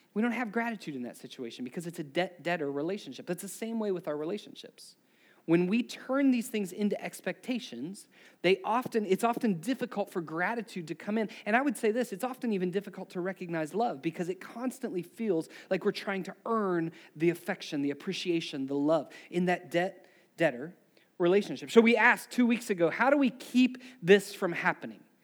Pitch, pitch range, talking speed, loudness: 195 Hz, 175-230 Hz, 195 wpm, -31 LUFS